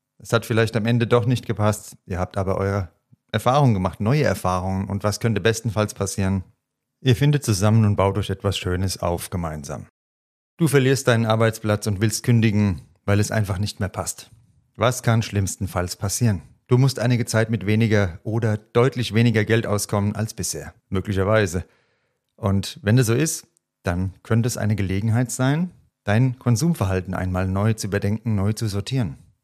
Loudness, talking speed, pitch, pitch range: -22 LUFS, 165 wpm, 110 Hz, 100-120 Hz